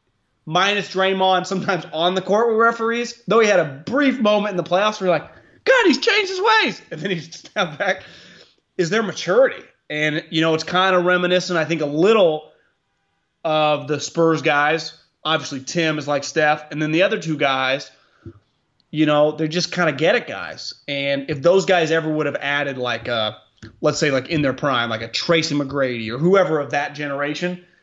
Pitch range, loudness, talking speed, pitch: 145-185 Hz, -19 LUFS, 200 wpm, 160 Hz